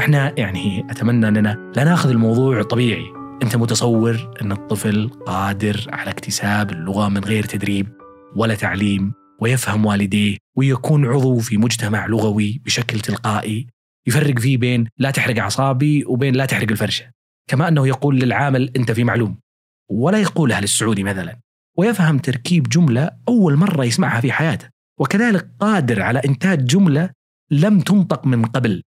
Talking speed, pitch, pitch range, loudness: 140 wpm, 120 Hz, 105-140 Hz, -18 LUFS